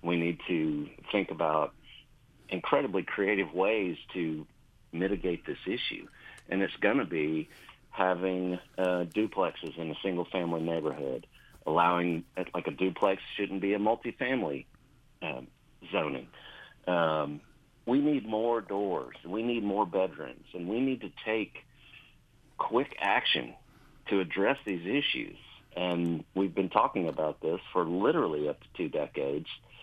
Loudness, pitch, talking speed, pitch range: -31 LUFS, 90 Hz, 135 wpm, 85-105 Hz